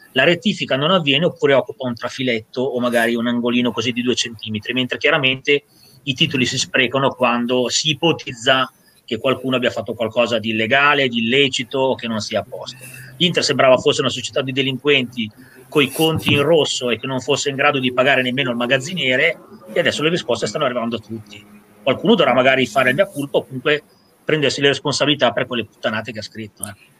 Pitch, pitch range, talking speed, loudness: 130 Hz, 120-140 Hz, 200 wpm, -17 LUFS